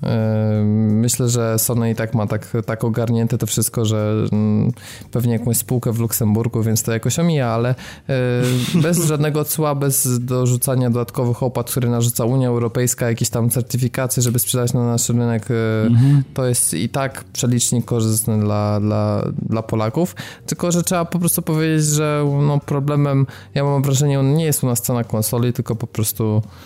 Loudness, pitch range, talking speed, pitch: -18 LUFS, 115-135 Hz, 165 wpm, 120 Hz